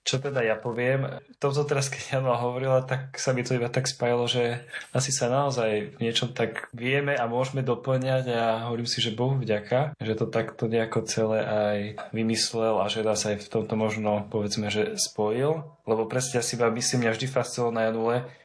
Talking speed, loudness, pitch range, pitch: 200 wpm, -27 LUFS, 110-130 Hz, 120 Hz